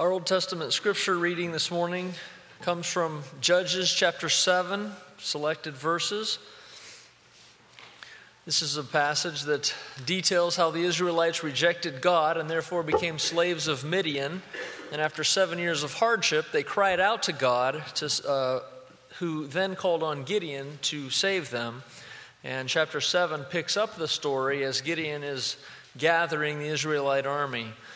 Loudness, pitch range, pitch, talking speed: -27 LUFS, 145-180 Hz, 165 Hz, 140 wpm